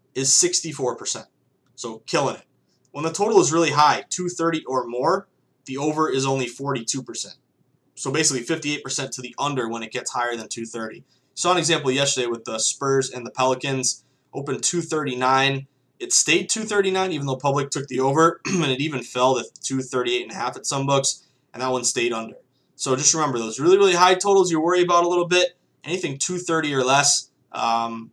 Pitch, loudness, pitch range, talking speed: 135 Hz, -21 LUFS, 130-165 Hz, 190 wpm